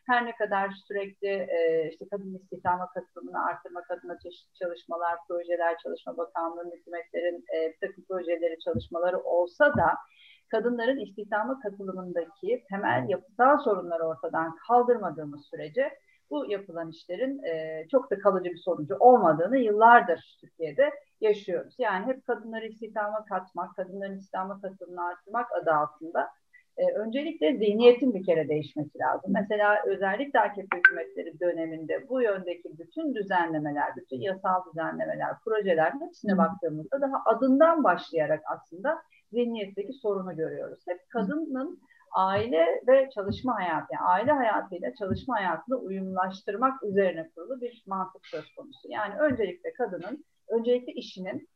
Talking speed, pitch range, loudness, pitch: 125 wpm, 175-245 Hz, -28 LUFS, 195 Hz